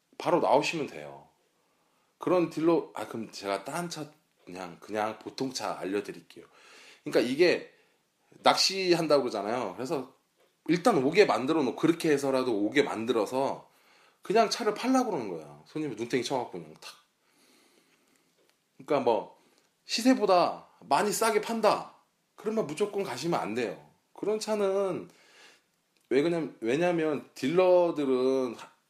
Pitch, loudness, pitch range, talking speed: 175 Hz, -28 LUFS, 140-215 Hz, 295 characters per minute